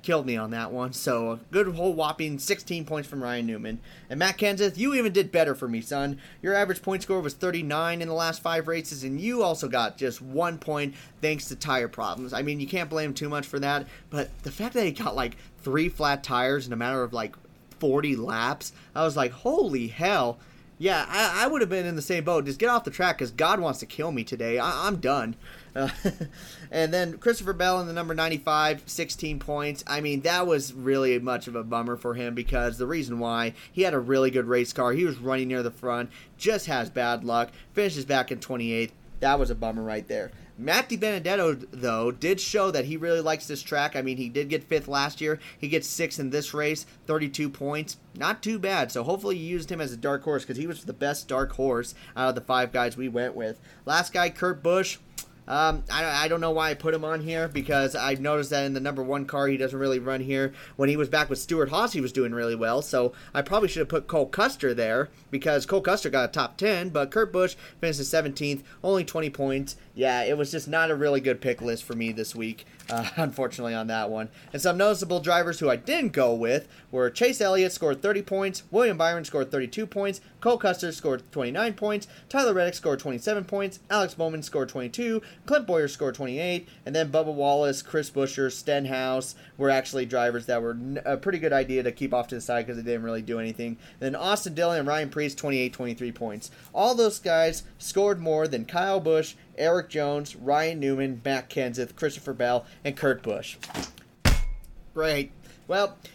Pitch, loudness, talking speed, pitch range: 145 Hz, -27 LUFS, 220 wpm, 130-170 Hz